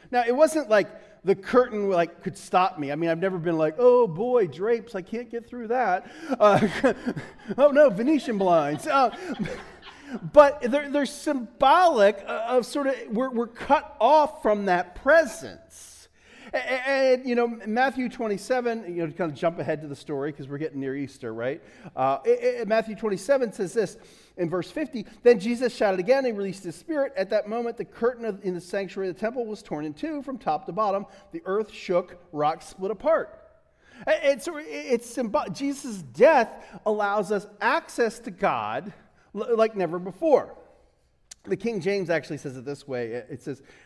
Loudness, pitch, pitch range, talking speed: -25 LUFS, 220 Hz, 185-255 Hz, 180 wpm